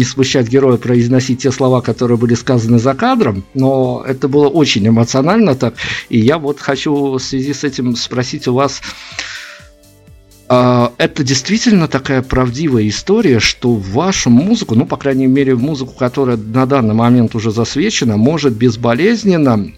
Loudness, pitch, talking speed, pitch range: -13 LUFS, 130 Hz, 150 wpm, 120-140 Hz